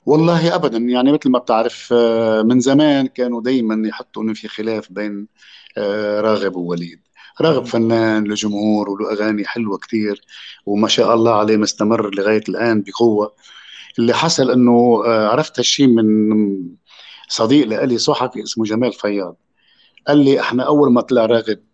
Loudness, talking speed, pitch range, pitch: -16 LUFS, 140 wpm, 105-125 Hz, 110 Hz